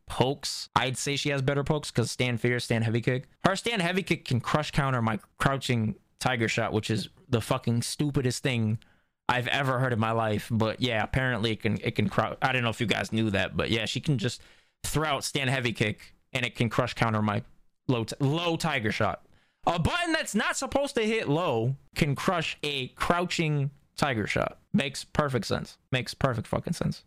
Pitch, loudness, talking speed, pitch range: 130 Hz, -28 LUFS, 210 wpm, 115-145 Hz